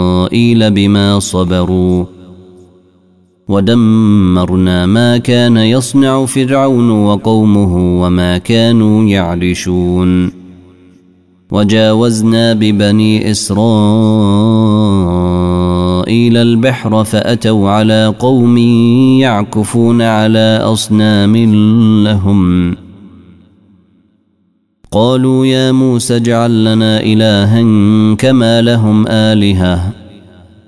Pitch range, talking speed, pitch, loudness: 90-115 Hz, 60 wpm, 105 Hz, -9 LUFS